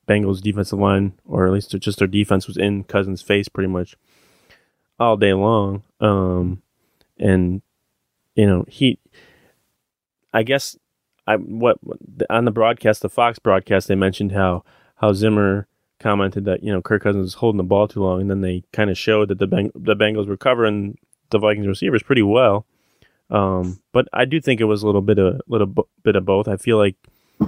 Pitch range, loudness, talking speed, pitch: 95-110 Hz, -19 LUFS, 190 wpm, 100 Hz